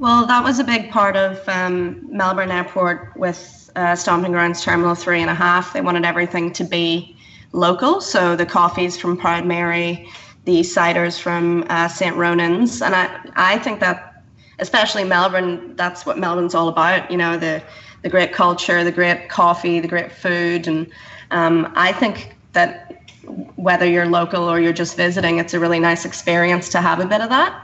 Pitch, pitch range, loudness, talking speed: 175 Hz, 170-180 Hz, -17 LUFS, 180 wpm